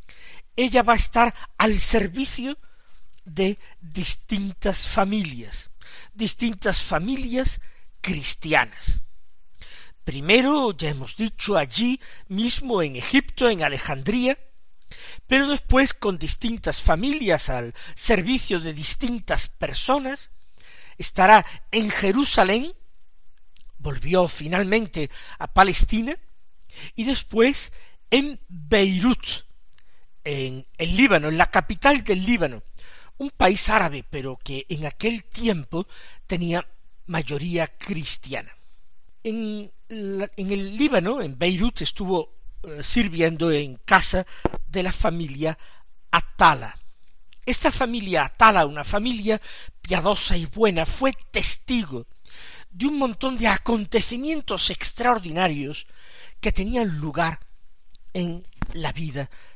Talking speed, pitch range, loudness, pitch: 100 wpm, 160-235 Hz, -22 LUFS, 200 Hz